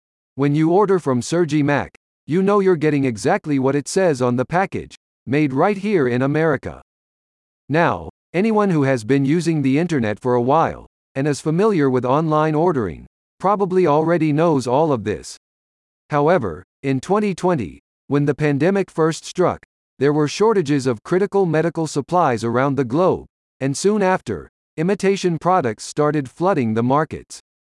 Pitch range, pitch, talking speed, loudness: 130-180 Hz, 150 Hz, 155 wpm, -19 LUFS